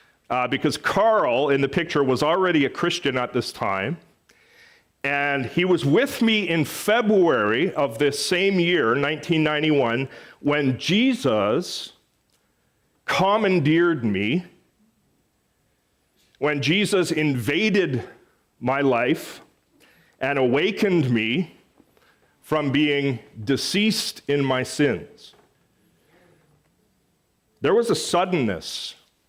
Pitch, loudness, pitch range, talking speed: 150 Hz, -22 LUFS, 140-185 Hz, 95 wpm